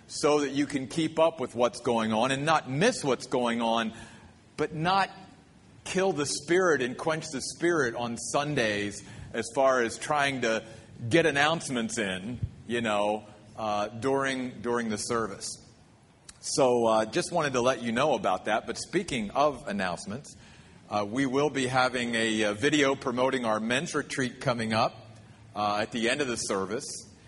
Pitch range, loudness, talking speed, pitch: 110-145 Hz, -28 LUFS, 170 wpm, 125 Hz